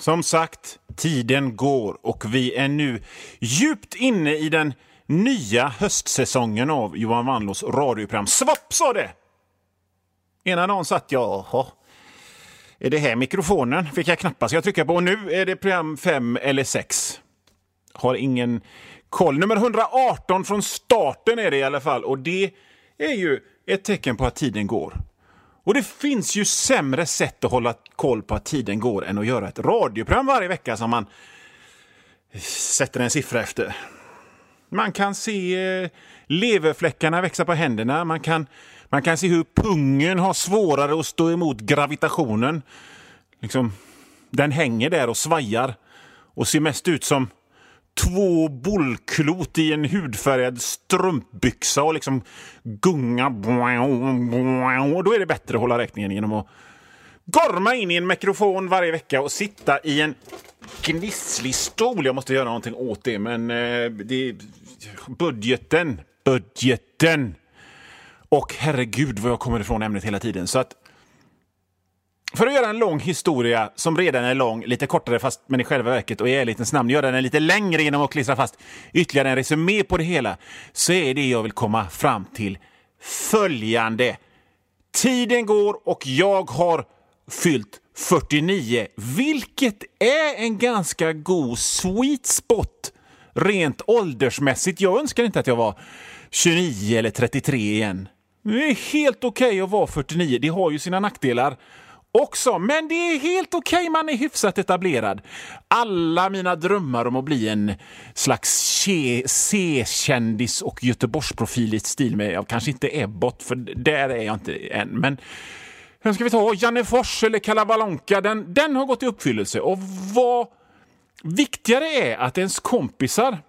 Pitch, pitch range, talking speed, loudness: 155 Hz, 125-195 Hz, 155 wpm, -21 LUFS